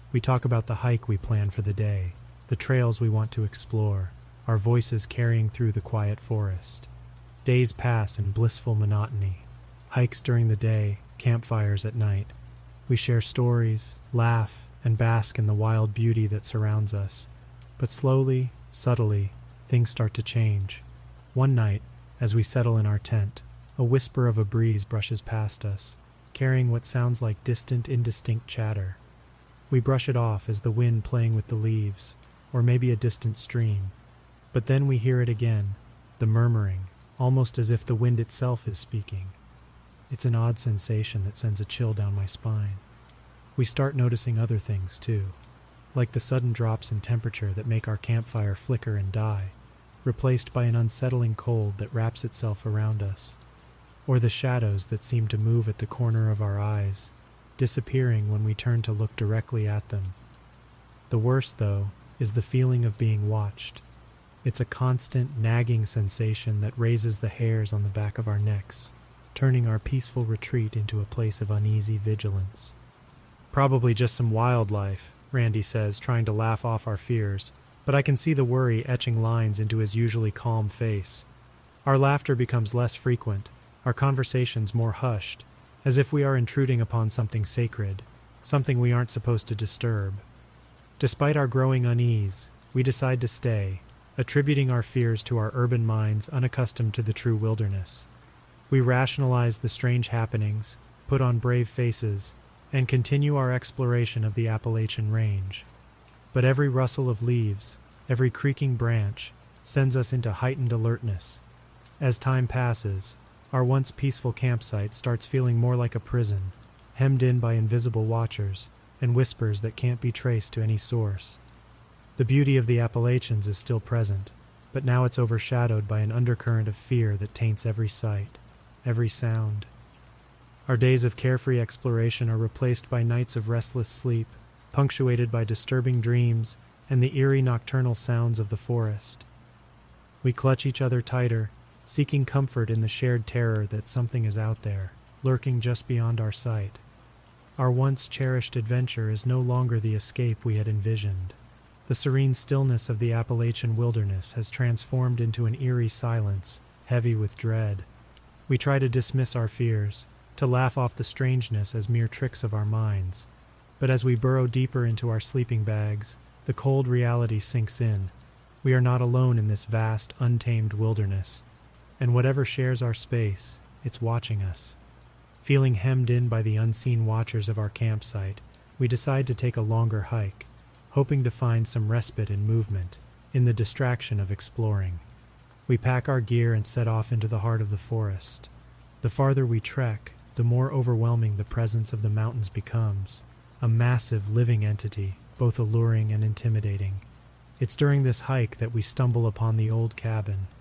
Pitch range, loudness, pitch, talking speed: 110-125 Hz, -26 LUFS, 115 Hz, 165 wpm